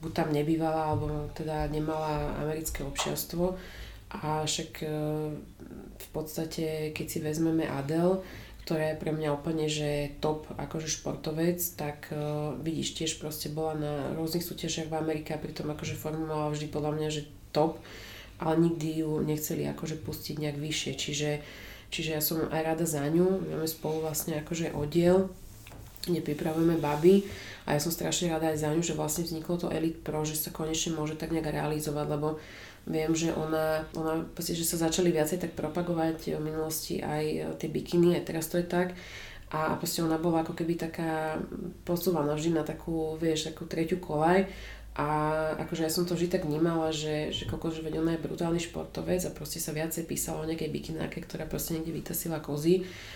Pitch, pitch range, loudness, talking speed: 155 Hz, 150-165 Hz, -31 LUFS, 175 wpm